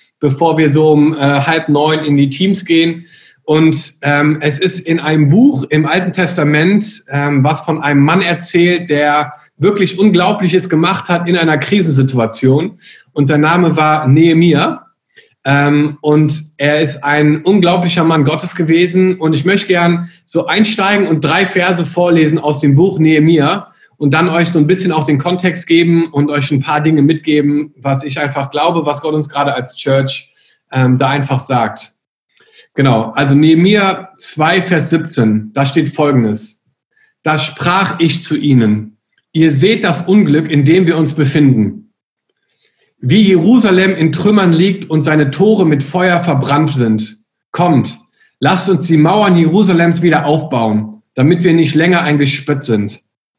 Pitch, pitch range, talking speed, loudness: 155 Hz, 145-175 Hz, 160 wpm, -12 LUFS